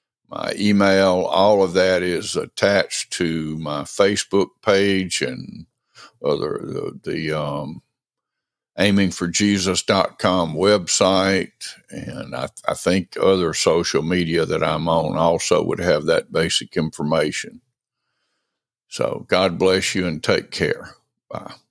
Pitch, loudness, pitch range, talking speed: 90 Hz, -20 LUFS, 80-95 Hz, 115 wpm